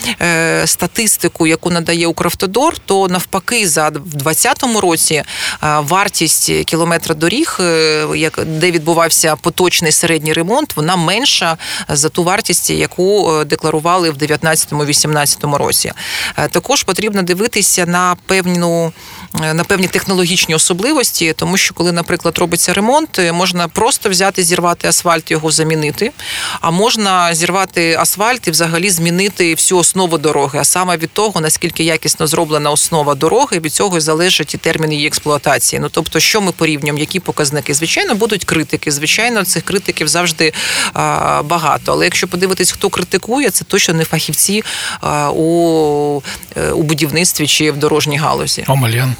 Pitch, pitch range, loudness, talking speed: 170 Hz, 155-185 Hz, -12 LUFS, 135 wpm